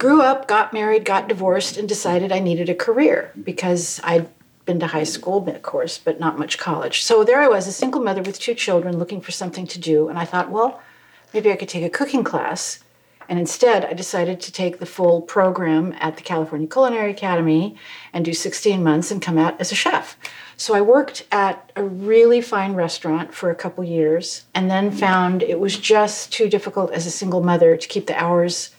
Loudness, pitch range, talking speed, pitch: -19 LUFS, 170-215 Hz, 215 wpm, 185 Hz